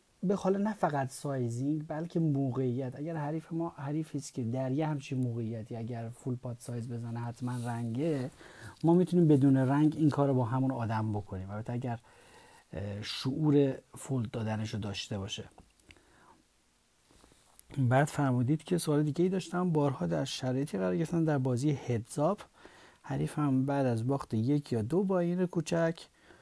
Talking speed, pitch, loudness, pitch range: 155 wpm, 135 Hz, -32 LUFS, 120-155 Hz